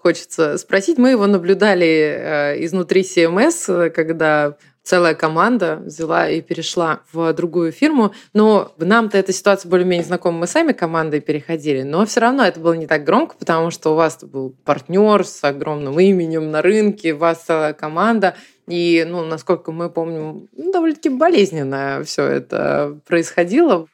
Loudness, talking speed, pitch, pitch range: -17 LUFS, 150 wpm, 170 Hz, 160-200 Hz